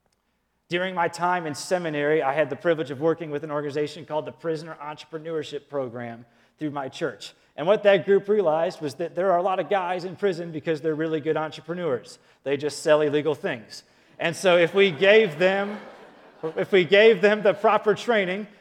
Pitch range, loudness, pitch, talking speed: 150-190 Hz, -23 LUFS, 165 Hz, 195 wpm